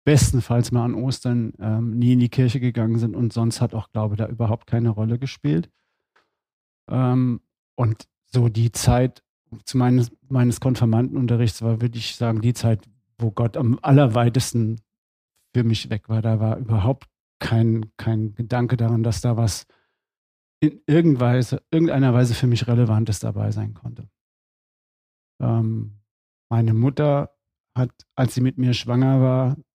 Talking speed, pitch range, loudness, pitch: 150 wpm, 115-125 Hz, -21 LUFS, 120 Hz